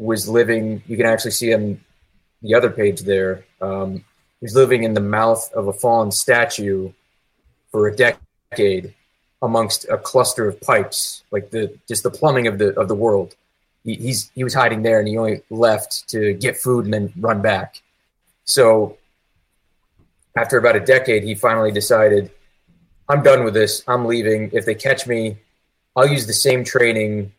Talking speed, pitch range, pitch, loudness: 175 wpm, 105-120 Hz, 110 Hz, -17 LUFS